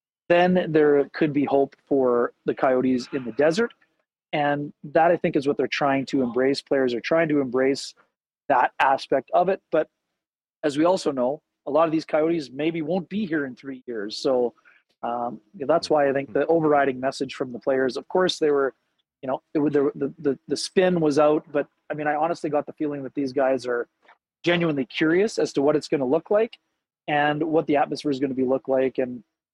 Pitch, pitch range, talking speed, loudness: 145 Hz, 135-160 Hz, 215 wpm, -23 LUFS